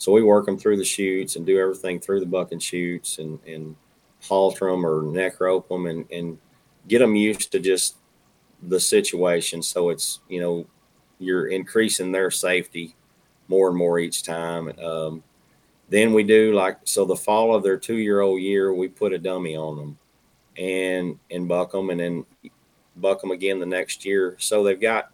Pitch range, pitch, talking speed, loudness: 85-95 Hz, 95 Hz, 190 wpm, -22 LUFS